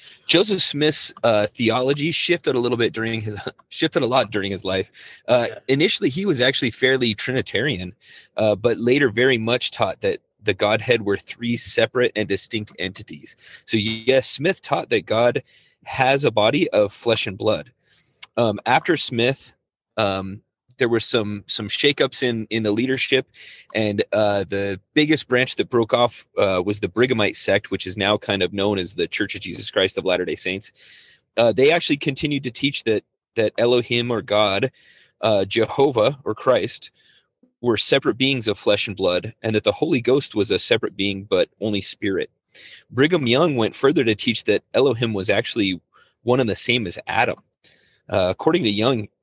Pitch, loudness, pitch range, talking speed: 115 Hz, -20 LUFS, 105-130 Hz, 180 wpm